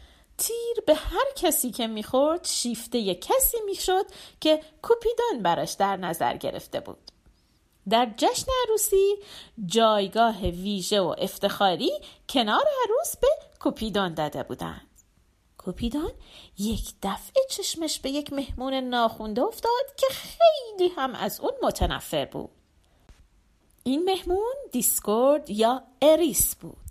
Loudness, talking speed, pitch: -25 LUFS, 115 wpm, 285 Hz